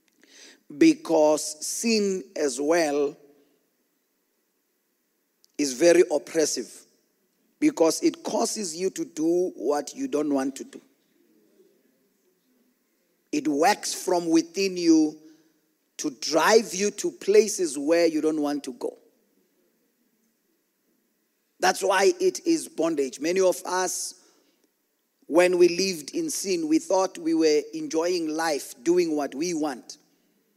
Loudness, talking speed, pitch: -24 LUFS, 115 wpm, 185 Hz